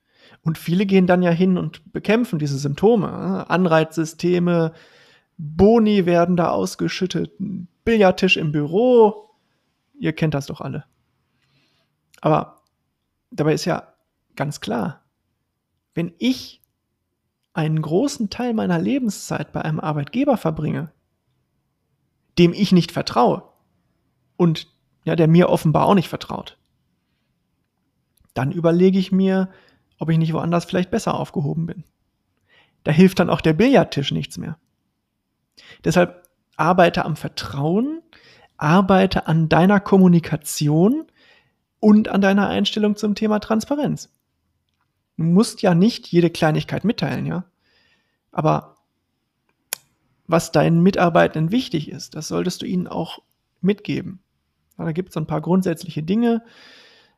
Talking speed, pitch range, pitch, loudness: 120 wpm, 160-200 Hz, 175 Hz, -19 LUFS